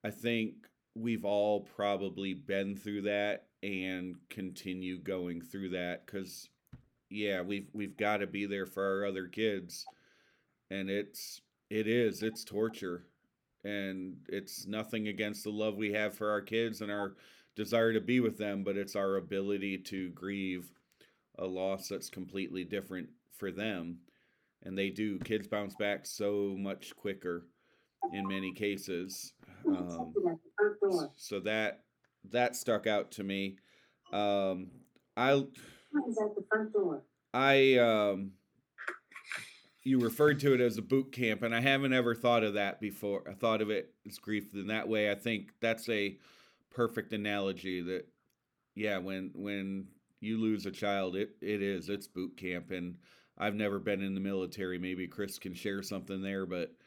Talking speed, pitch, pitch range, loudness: 155 wpm, 100 Hz, 95-110 Hz, -35 LUFS